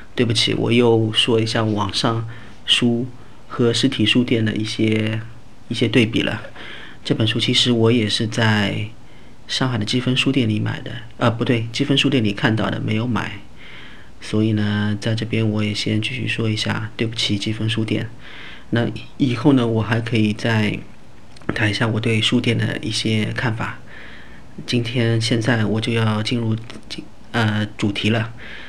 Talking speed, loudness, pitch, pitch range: 235 characters per minute, -19 LUFS, 115 Hz, 110-120 Hz